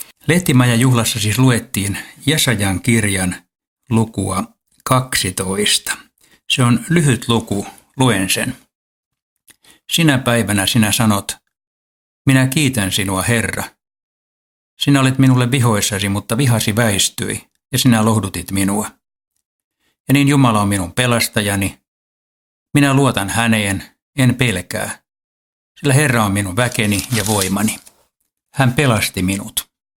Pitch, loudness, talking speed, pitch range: 115 Hz, -16 LUFS, 110 wpm, 100-130 Hz